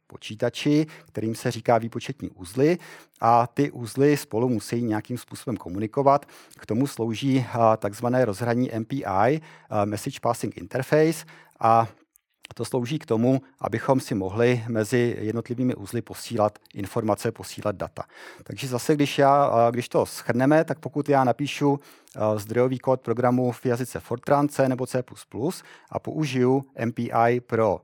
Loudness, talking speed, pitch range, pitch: -24 LUFS, 135 wpm, 115-135 Hz, 120 Hz